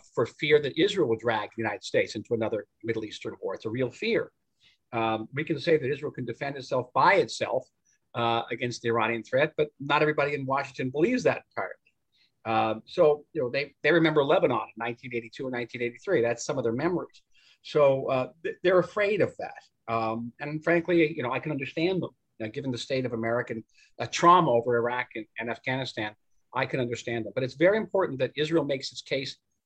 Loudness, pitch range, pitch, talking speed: -27 LUFS, 115-155 Hz, 130 Hz, 200 wpm